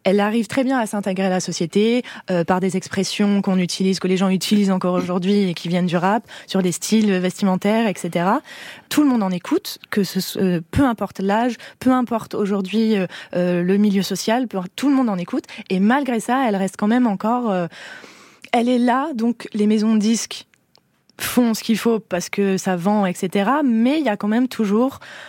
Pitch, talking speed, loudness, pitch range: 205 Hz, 210 wpm, -20 LUFS, 190-235 Hz